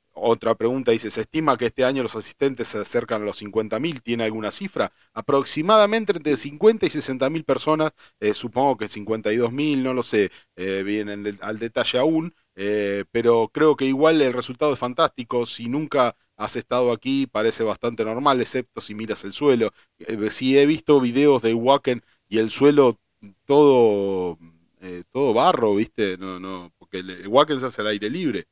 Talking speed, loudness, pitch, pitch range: 175 wpm, -22 LUFS, 120 Hz, 105-140 Hz